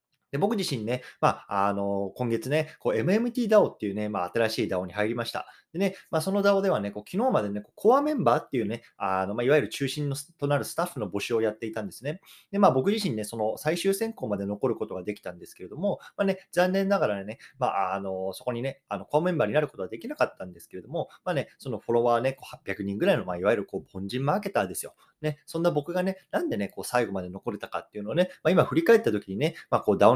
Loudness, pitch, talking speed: -28 LUFS, 135 Hz, 495 characters per minute